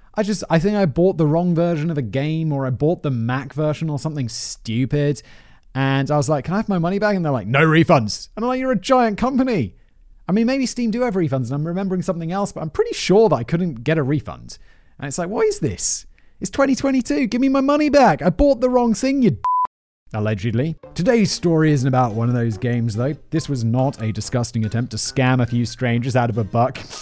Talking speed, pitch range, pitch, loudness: 245 wpm, 125-210 Hz, 155 Hz, -19 LUFS